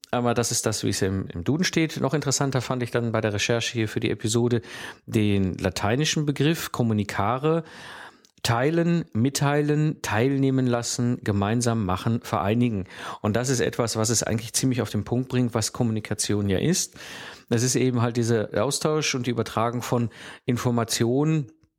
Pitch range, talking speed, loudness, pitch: 110-130 Hz, 160 wpm, -24 LUFS, 120 Hz